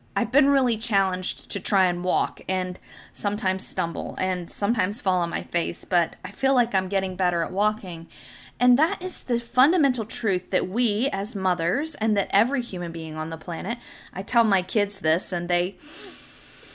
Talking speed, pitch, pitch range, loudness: 185 wpm, 195 Hz, 180-235 Hz, -24 LUFS